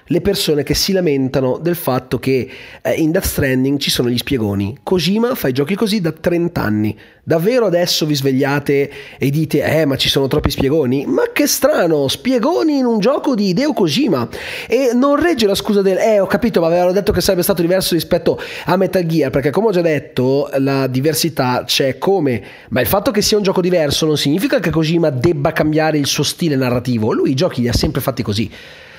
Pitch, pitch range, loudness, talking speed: 160 Hz, 140-195 Hz, -15 LUFS, 205 wpm